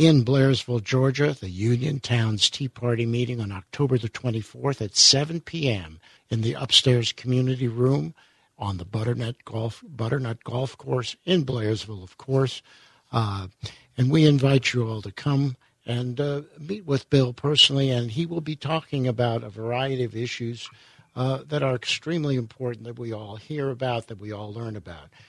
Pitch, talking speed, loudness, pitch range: 125 Hz, 170 wpm, -24 LUFS, 115-140 Hz